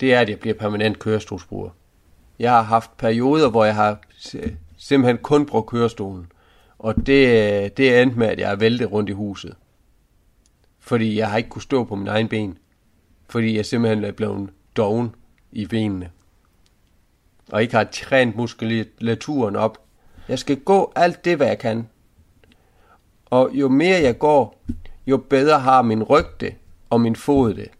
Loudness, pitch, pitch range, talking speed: -19 LUFS, 110 Hz, 100-120 Hz, 165 wpm